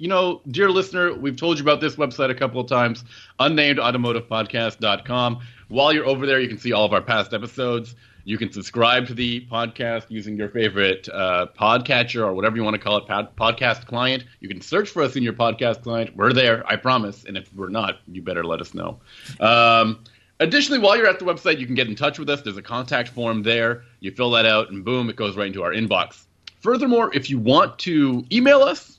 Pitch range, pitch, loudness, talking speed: 110-135 Hz, 120 Hz, -20 LUFS, 225 wpm